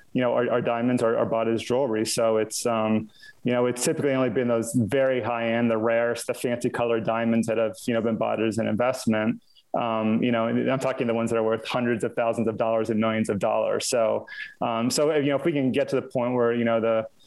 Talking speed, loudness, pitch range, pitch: 260 wpm, -25 LUFS, 115-125 Hz, 115 Hz